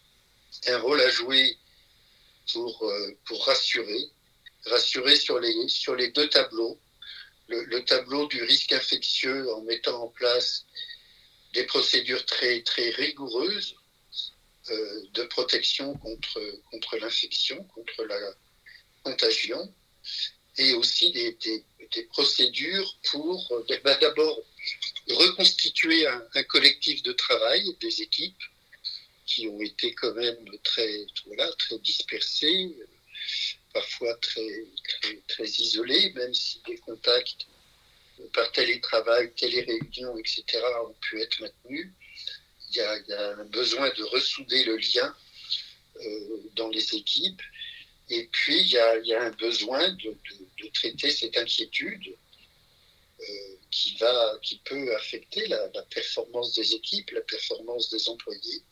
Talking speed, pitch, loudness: 130 wpm, 380 Hz, -25 LUFS